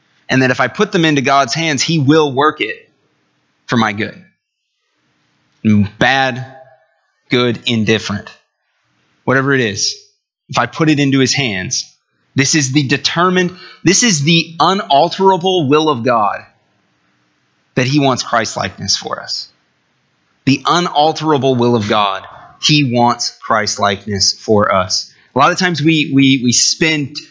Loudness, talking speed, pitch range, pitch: -13 LUFS, 145 wpm, 120-165 Hz, 140 Hz